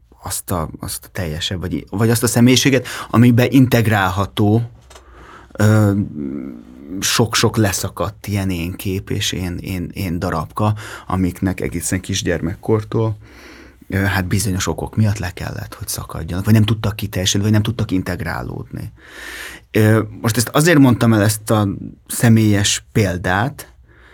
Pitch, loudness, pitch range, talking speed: 105 Hz, -17 LUFS, 95-115 Hz, 130 wpm